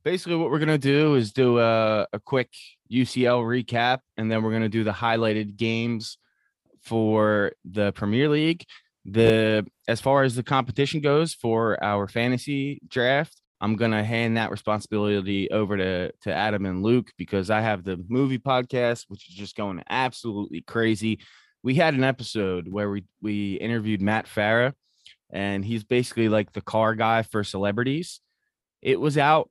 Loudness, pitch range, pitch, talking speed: -24 LUFS, 105-125 Hz, 115 Hz, 170 wpm